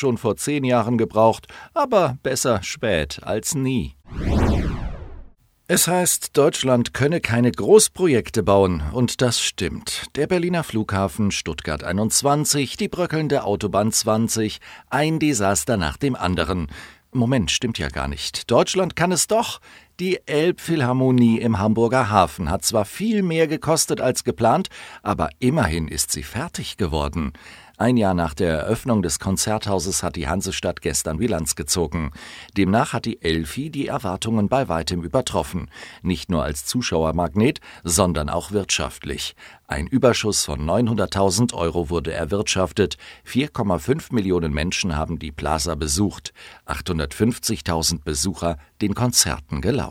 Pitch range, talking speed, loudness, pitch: 85-130 Hz, 130 wpm, -21 LUFS, 105 Hz